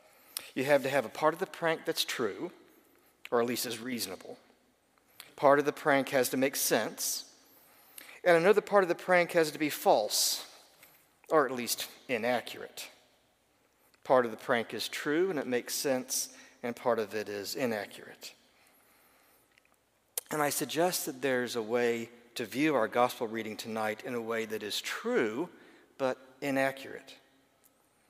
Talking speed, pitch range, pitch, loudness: 160 wpm, 120-155 Hz, 135 Hz, -31 LUFS